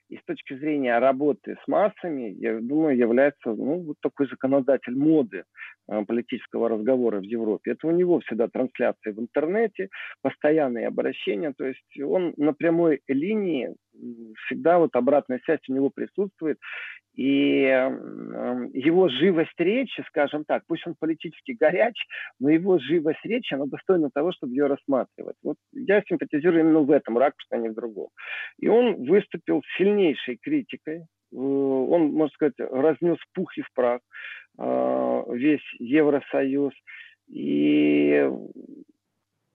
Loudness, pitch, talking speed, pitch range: -24 LUFS, 145 Hz, 135 wpm, 125-170 Hz